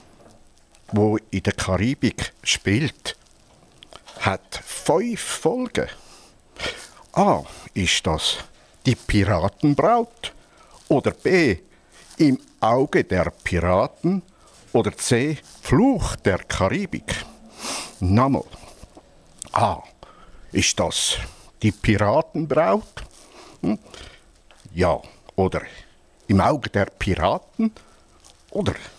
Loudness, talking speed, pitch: -22 LUFS, 80 wpm, 120 Hz